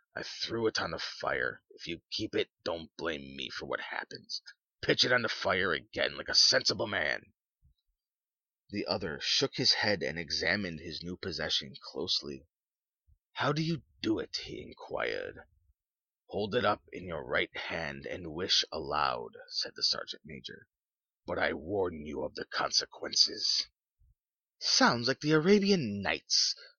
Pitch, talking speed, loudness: 130 Hz, 155 wpm, -31 LUFS